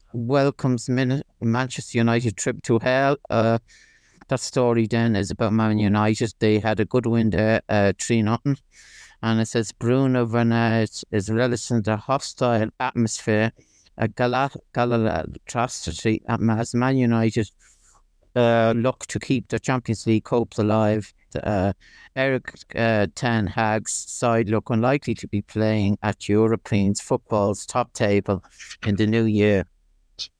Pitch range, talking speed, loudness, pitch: 105-120 Hz, 140 wpm, -22 LUFS, 115 Hz